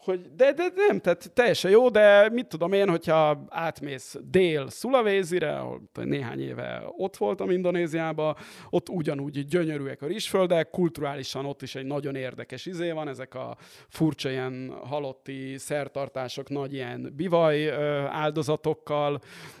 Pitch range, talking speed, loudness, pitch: 135-180 Hz, 135 wpm, -26 LUFS, 155 Hz